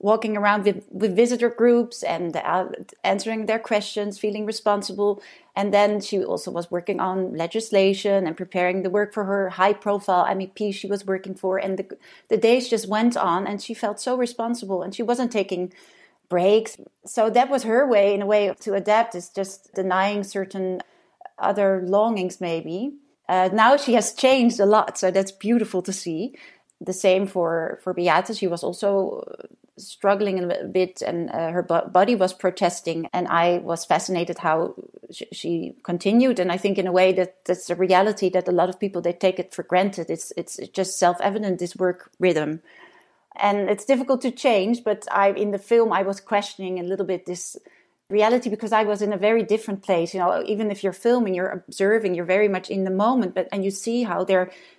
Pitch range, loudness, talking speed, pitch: 185-220 Hz, -22 LUFS, 195 wpm, 195 Hz